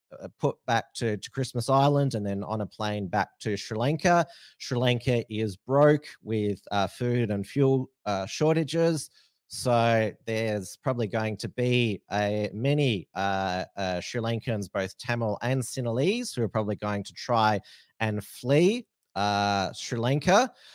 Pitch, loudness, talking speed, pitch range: 115 Hz, -27 LUFS, 155 wpm, 105-135 Hz